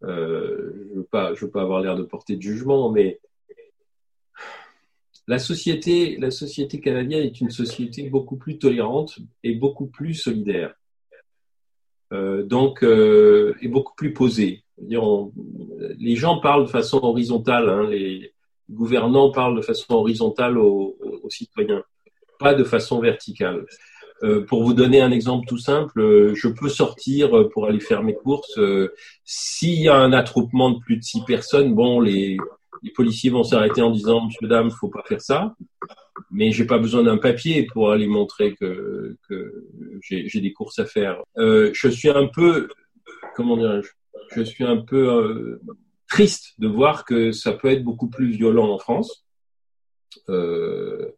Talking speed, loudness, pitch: 160 wpm, -20 LUFS, 135 Hz